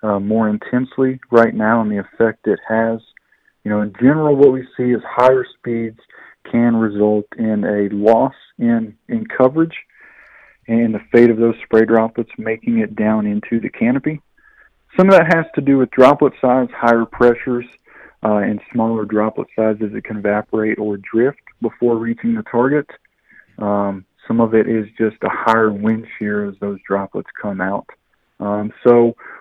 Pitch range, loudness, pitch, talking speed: 105-125 Hz, -16 LUFS, 115 Hz, 170 wpm